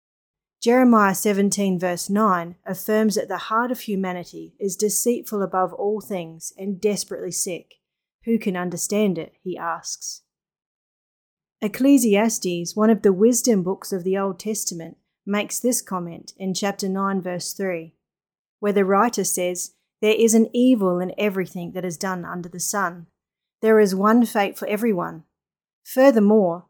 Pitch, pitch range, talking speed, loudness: 195 Hz, 180-215 Hz, 145 wpm, -21 LUFS